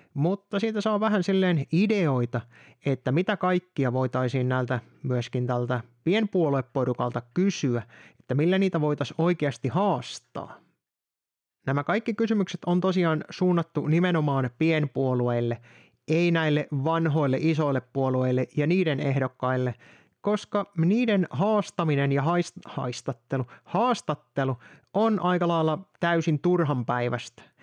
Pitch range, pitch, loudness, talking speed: 130-180 Hz, 150 Hz, -26 LUFS, 105 wpm